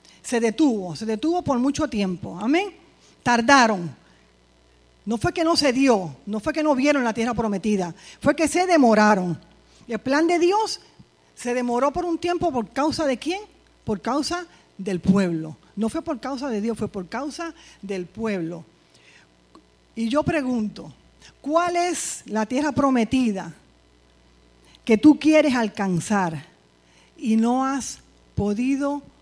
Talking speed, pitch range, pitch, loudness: 150 wpm, 190-300 Hz, 235 Hz, -22 LUFS